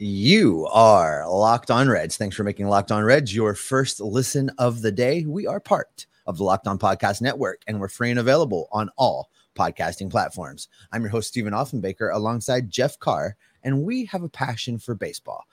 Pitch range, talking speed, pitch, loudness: 105-130 Hz, 195 wpm, 115 Hz, -22 LUFS